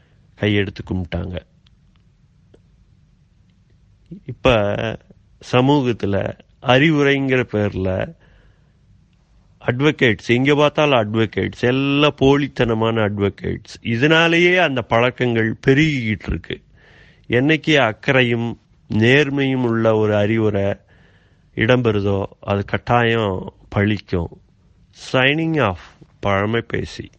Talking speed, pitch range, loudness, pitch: 70 wpm, 100-135 Hz, -18 LUFS, 115 Hz